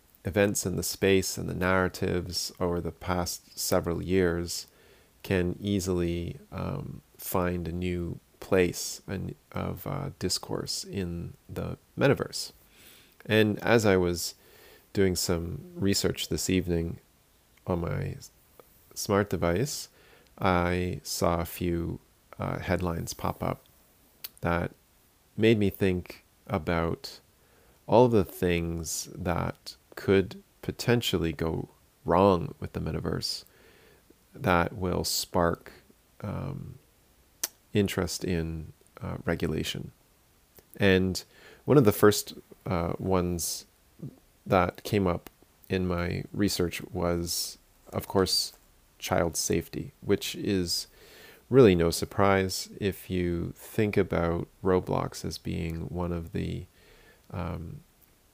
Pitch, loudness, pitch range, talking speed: 90 Hz, -29 LUFS, 85-95 Hz, 110 wpm